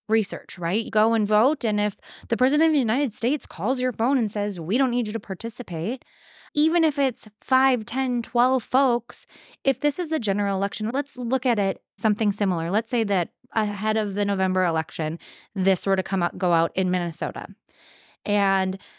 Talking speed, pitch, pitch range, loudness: 195 wpm, 220 Hz, 195-255 Hz, -24 LUFS